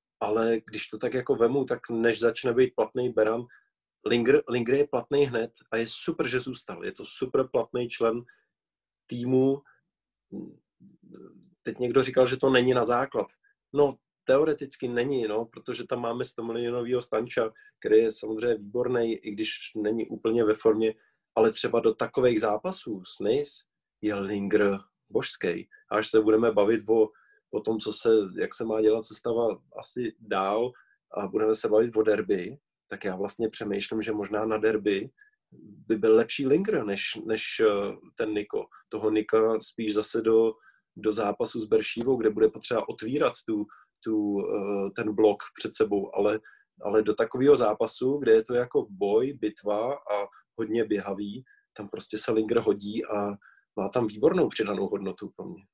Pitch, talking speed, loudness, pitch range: 115 Hz, 160 wpm, -27 LUFS, 110-140 Hz